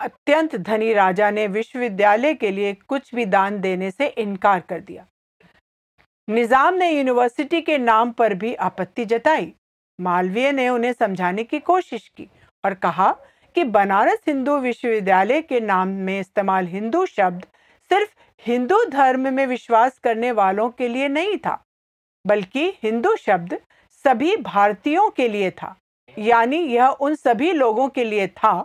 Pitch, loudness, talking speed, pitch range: 235 Hz, -20 LUFS, 145 wpm, 205-285 Hz